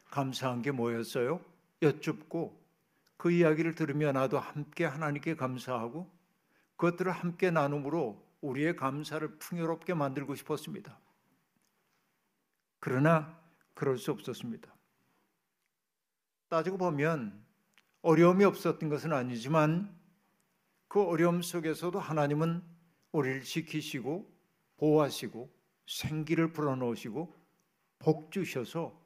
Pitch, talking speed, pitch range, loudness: 160 Hz, 260 characters per minute, 145-175 Hz, -32 LUFS